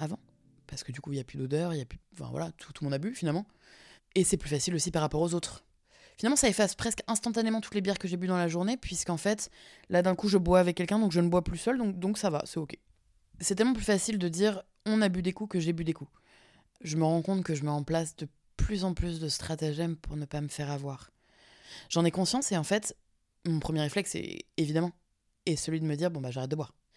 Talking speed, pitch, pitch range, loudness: 270 wpm, 170 Hz, 150-195 Hz, -31 LUFS